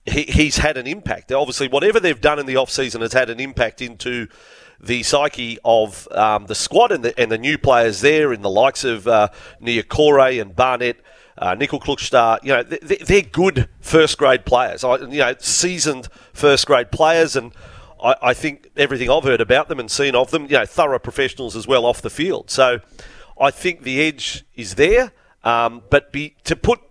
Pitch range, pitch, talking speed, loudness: 120-150 Hz, 135 Hz, 200 wpm, -17 LUFS